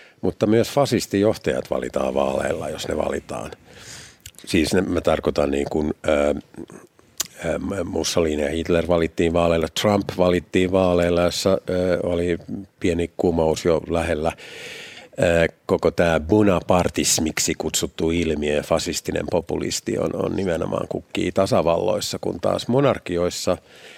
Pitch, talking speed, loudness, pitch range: 85 Hz, 120 wpm, -21 LUFS, 80-90 Hz